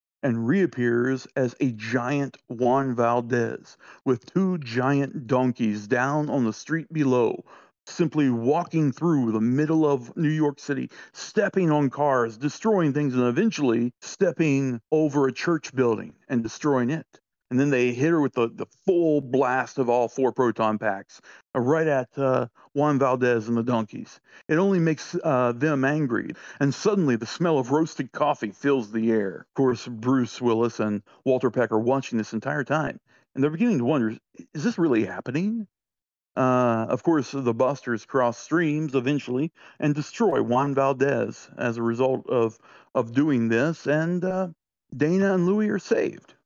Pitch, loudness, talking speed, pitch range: 135 Hz, -24 LUFS, 165 wpm, 120-150 Hz